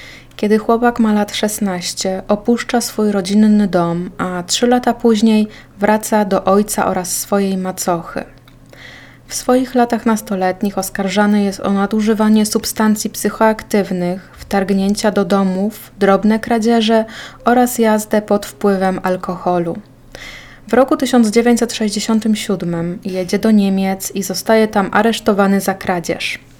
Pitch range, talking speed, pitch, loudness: 190-220 Hz, 115 wpm, 205 Hz, -15 LUFS